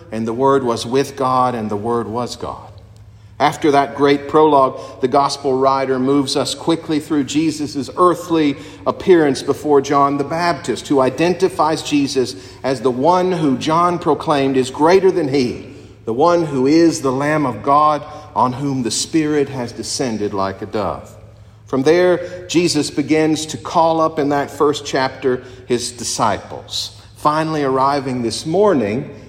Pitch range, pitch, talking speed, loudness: 120-155 Hz, 140 Hz, 155 wpm, -17 LUFS